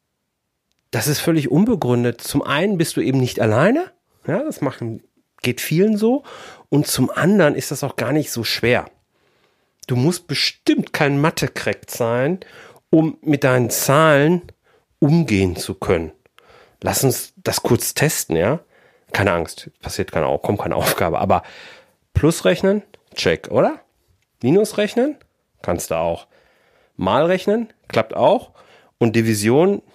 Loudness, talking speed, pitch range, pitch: -19 LUFS, 140 wpm, 125-190 Hz, 150 Hz